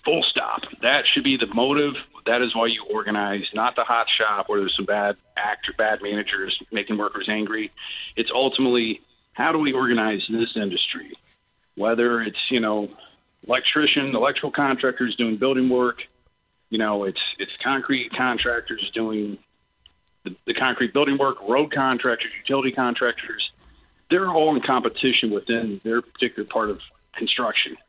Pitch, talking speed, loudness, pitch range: 115 Hz, 155 wpm, -22 LUFS, 105-130 Hz